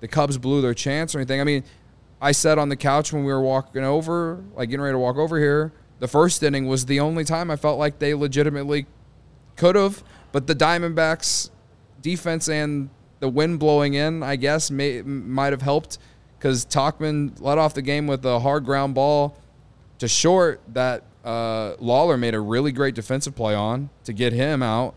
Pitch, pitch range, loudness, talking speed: 140 Hz, 130-150 Hz, -22 LUFS, 195 wpm